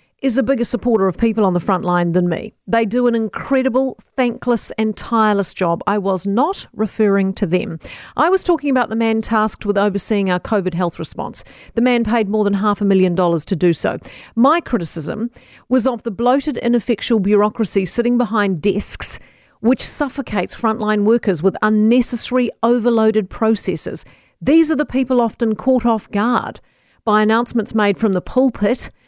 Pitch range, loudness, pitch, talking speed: 200-240 Hz, -17 LUFS, 220 Hz, 175 wpm